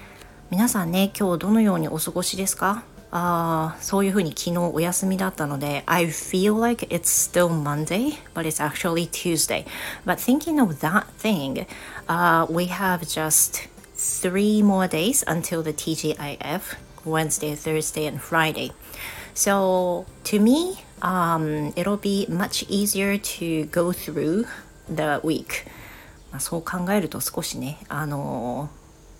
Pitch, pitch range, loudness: 175 Hz, 155-195 Hz, -23 LUFS